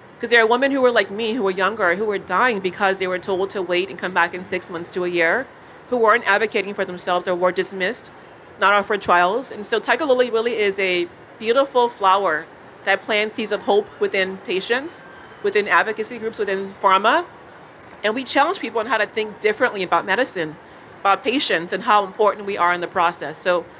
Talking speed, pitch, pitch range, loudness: 210 wpm, 200 Hz, 185-225 Hz, -20 LUFS